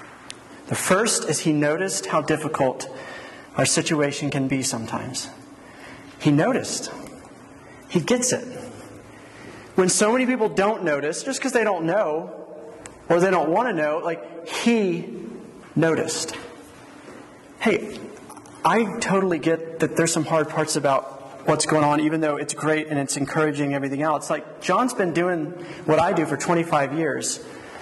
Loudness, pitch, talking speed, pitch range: -22 LUFS, 160 Hz, 150 wpm, 150-180 Hz